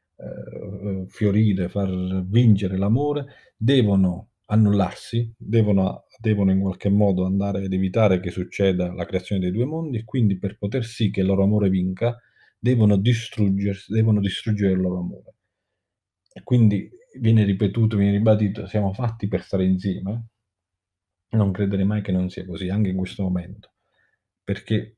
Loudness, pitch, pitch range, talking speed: -22 LUFS, 100 Hz, 95-110 Hz, 145 wpm